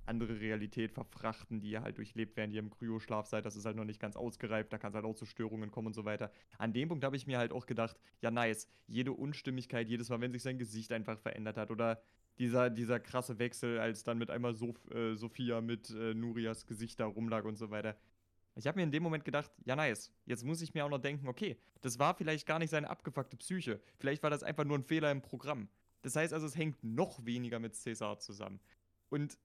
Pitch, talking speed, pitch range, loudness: 115 Hz, 240 wpm, 110-135 Hz, -39 LUFS